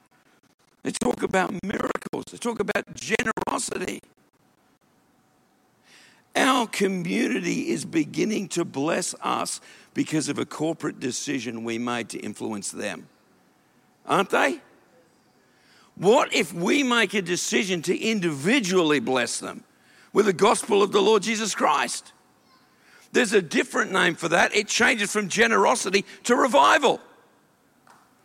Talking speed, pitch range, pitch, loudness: 120 wpm, 170-220 Hz, 200 Hz, -23 LUFS